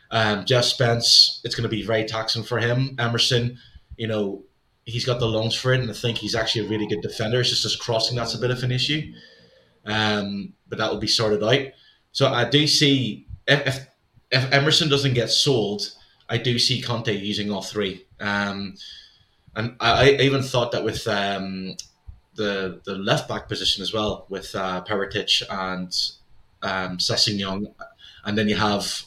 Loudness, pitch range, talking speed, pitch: -22 LUFS, 105-125 Hz, 185 wpm, 110 Hz